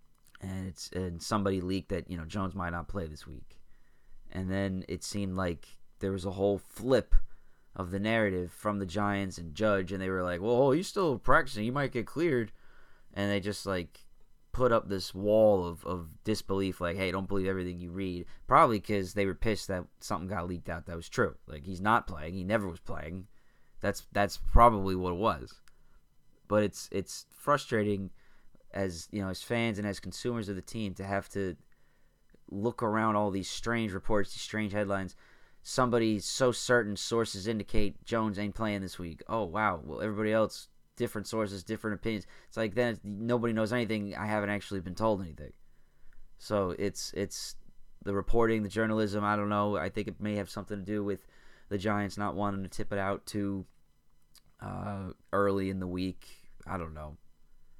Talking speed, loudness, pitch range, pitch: 190 wpm, -32 LUFS, 90-105 Hz, 100 Hz